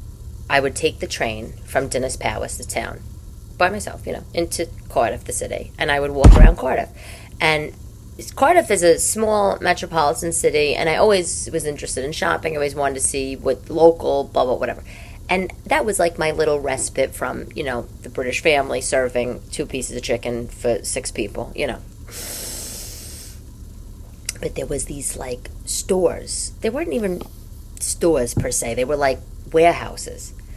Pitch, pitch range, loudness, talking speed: 140 Hz, 115-165 Hz, -20 LUFS, 170 wpm